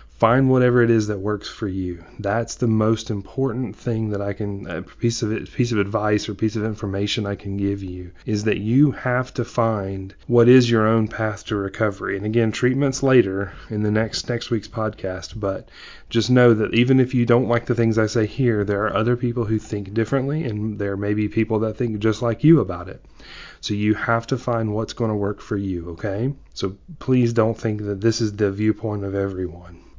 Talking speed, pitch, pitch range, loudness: 220 wpm, 110 Hz, 100-120 Hz, -21 LUFS